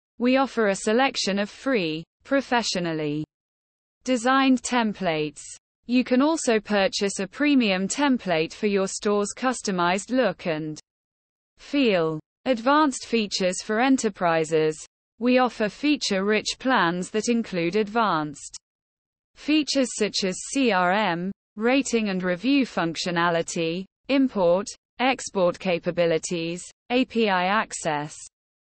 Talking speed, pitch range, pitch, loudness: 100 wpm, 175-255 Hz, 205 Hz, -24 LUFS